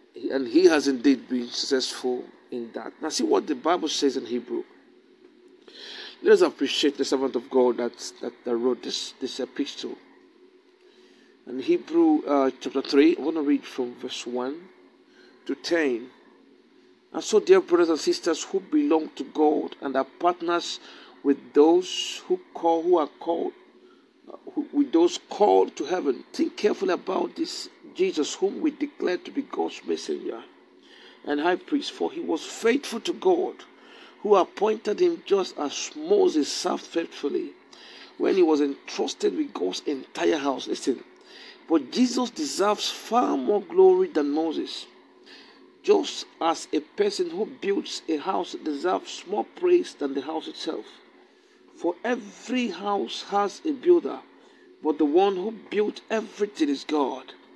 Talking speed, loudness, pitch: 150 wpm, -25 LUFS, 320 Hz